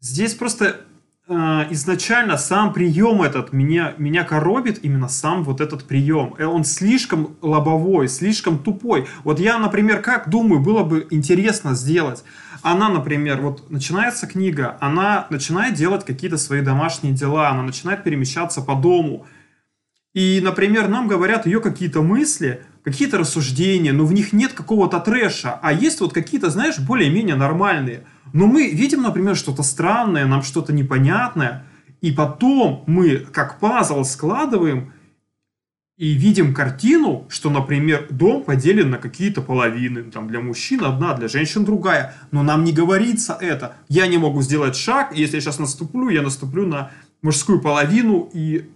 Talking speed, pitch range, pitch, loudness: 150 wpm, 145-195 Hz, 165 Hz, -18 LUFS